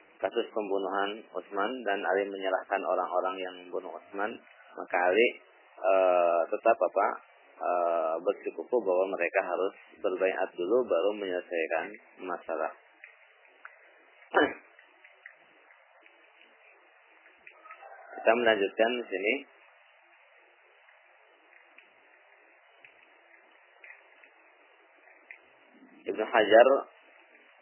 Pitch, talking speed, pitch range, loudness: 100 Hz, 65 wpm, 95-115 Hz, -29 LUFS